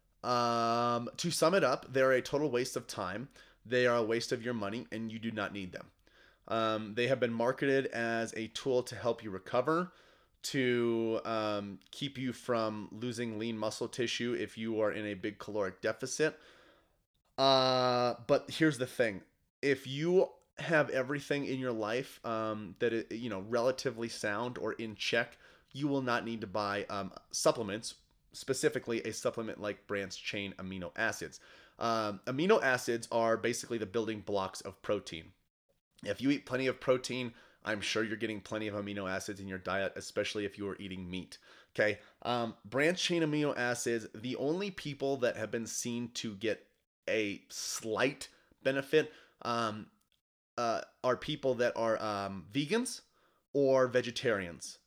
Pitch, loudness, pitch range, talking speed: 115 Hz, -34 LUFS, 105-130 Hz, 165 wpm